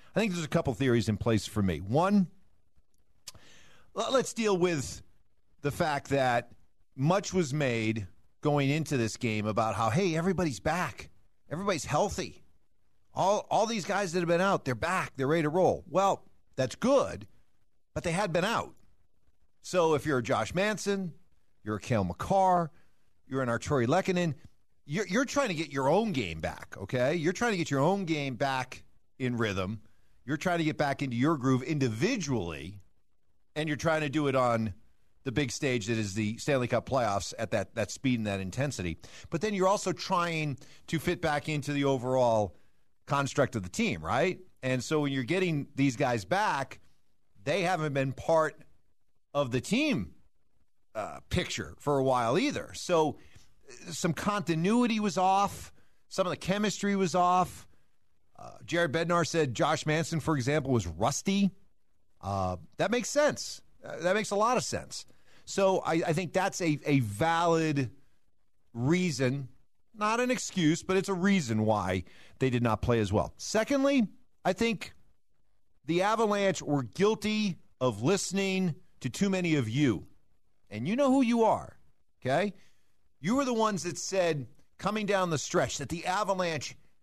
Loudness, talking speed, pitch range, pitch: -30 LUFS, 170 wpm, 115-185 Hz, 145 Hz